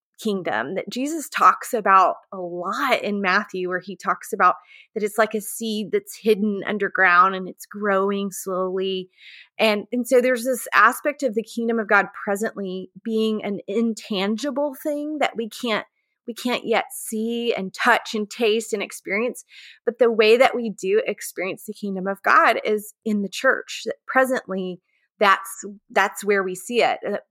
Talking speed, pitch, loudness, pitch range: 170 wpm, 215 Hz, -22 LUFS, 195-240 Hz